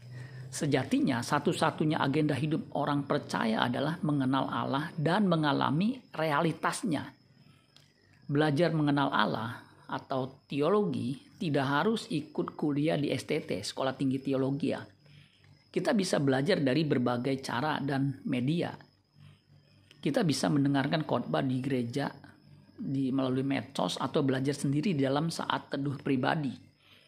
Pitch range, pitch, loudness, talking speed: 135-155 Hz, 140 Hz, -30 LUFS, 110 wpm